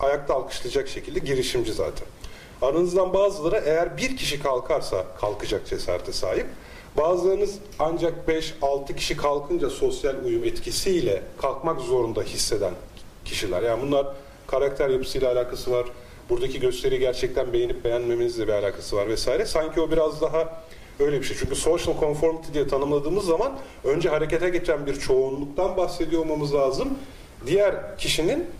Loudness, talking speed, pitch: -25 LUFS, 135 wpm, 170 Hz